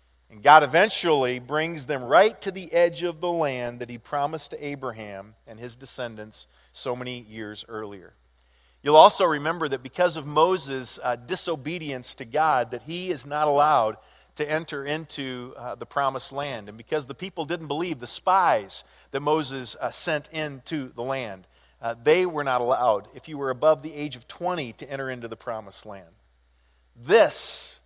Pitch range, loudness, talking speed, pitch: 115-155 Hz, -24 LUFS, 170 wpm, 135 Hz